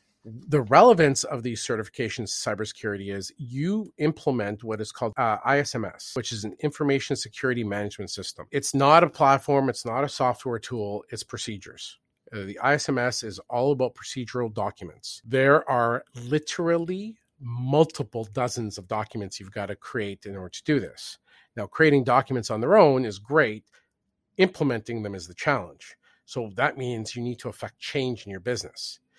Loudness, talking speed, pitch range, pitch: -25 LUFS, 165 wpm, 110-140 Hz, 125 Hz